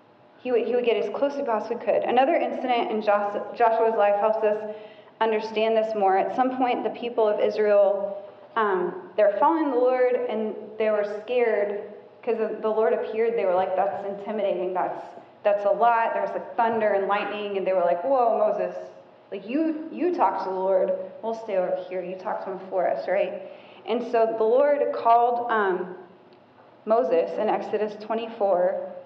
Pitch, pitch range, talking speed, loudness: 215 Hz, 200-235 Hz, 185 wpm, -24 LUFS